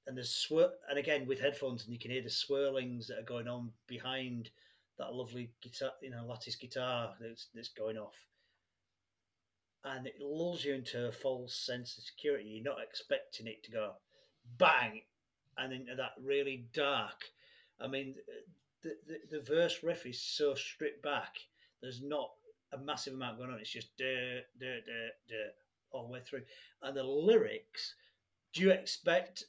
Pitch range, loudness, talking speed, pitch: 120-140 Hz, -38 LUFS, 175 wpm, 130 Hz